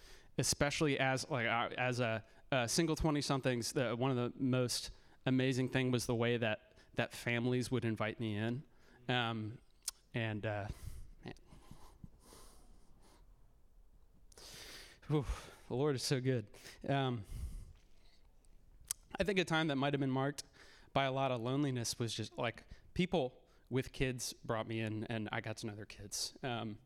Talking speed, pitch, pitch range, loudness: 145 wpm, 125 Hz, 115-135 Hz, -37 LUFS